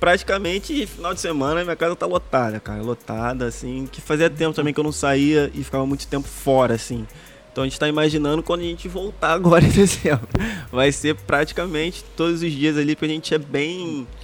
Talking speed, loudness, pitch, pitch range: 205 wpm, -21 LUFS, 150 Hz, 135-165 Hz